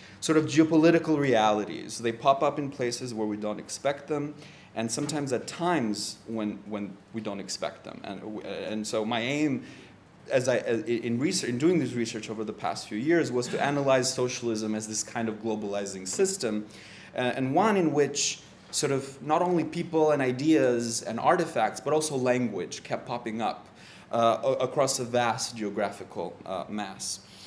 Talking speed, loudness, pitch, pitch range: 170 wpm, -28 LUFS, 125 Hz, 110-145 Hz